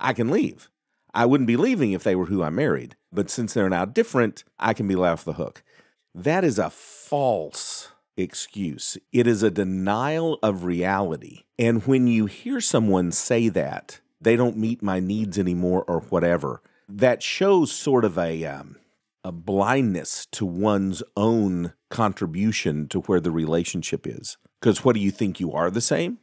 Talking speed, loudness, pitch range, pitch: 175 wpm, -23 LUFS, 90-120 Hz, 100 Hz